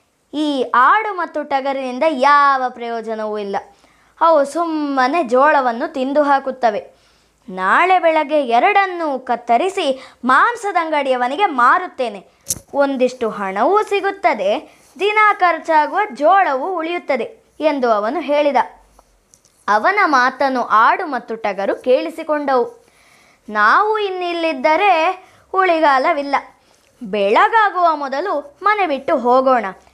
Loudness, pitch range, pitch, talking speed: -16 LUFS, 255-345 Hz, 290 Hz, 85 wpm